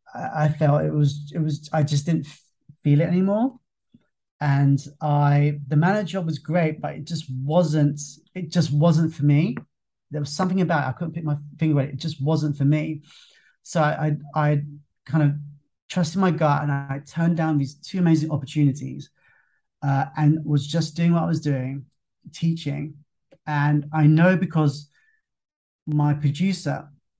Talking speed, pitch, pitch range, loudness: 170 wpm, 150 Hz, 145-165 Hz, -23 LUFS